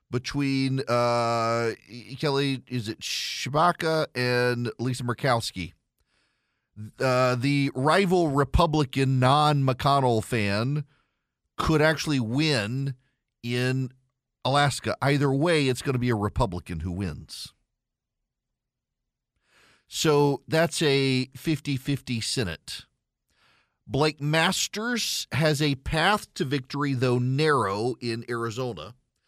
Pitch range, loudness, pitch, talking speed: 120-145 Hz, -25 LUFS, 130 Hz, 100 wpm